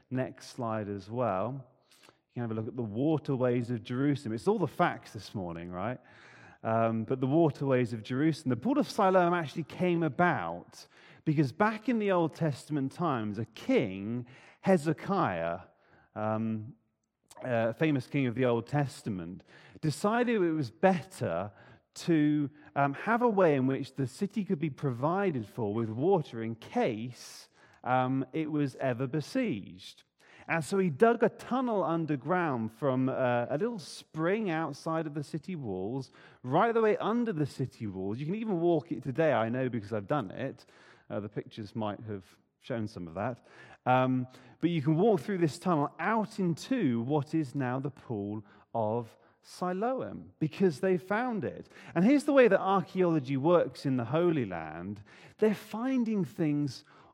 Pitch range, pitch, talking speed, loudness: 120-175 Hz, 145 Hz, 165 wpm, -31 LUFS